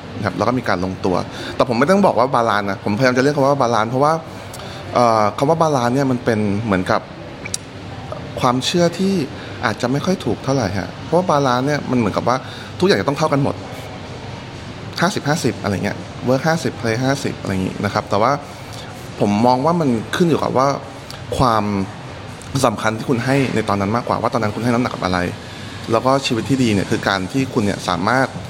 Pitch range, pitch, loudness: 105-135 Hz, 120 Hz, -18 LUFS